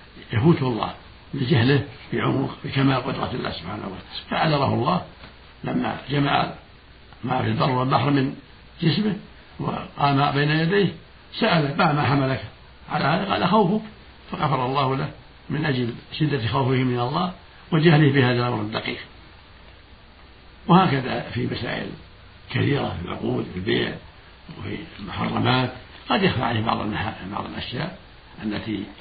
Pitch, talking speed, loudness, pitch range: 130 Hz, 125 wpm, -23 LUFS, 110-150 Hz